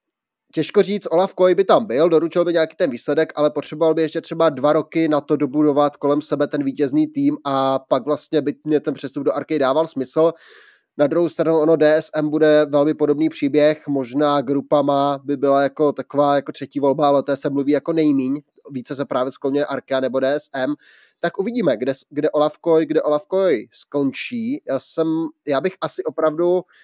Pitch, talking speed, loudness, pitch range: 150 Hz, 190 wpm, -19 LUFS, 140-160 Hz